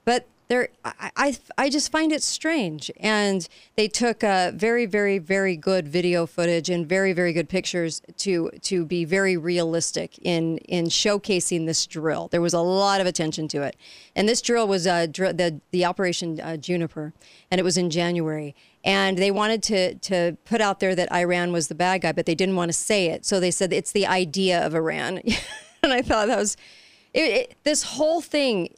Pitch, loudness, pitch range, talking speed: 185 Hz, -23 LUFS, 170-210 Hz, 200 wpm